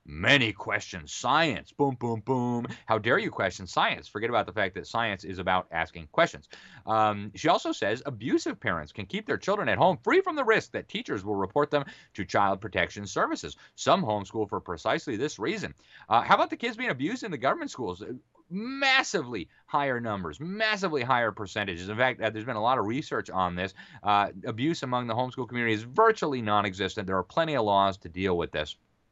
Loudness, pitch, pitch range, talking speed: -28 LUFS, 115 Hz, 100-145 Hz, 200 wpm